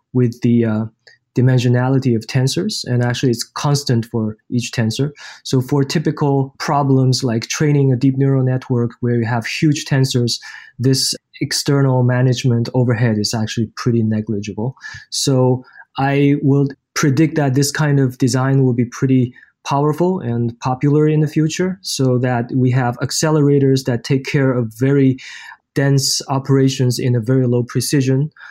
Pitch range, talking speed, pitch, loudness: 120-140 Hz, 150 wpm, 130 Hz, -17 LUFS